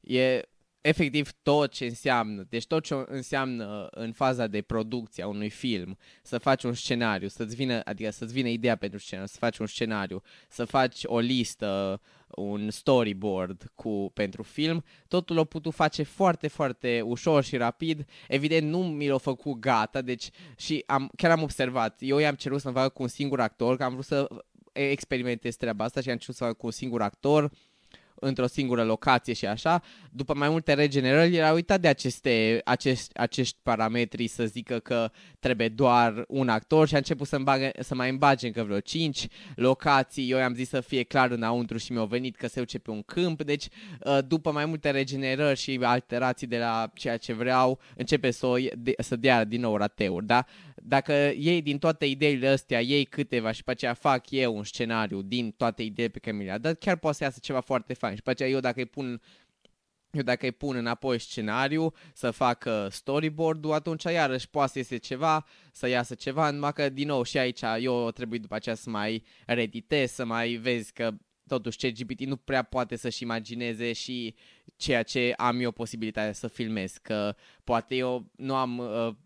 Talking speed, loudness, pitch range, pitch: 195 wpm, -28 LUFS, 115-140 Hz, 125 Hz